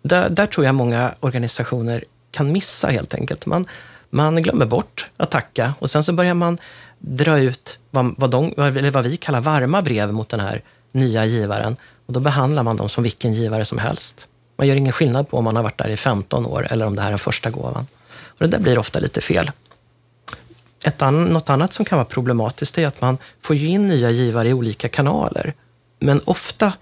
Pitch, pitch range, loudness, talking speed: 130 Hz, 115-155 Hz, -19 LUFS, 205 wpm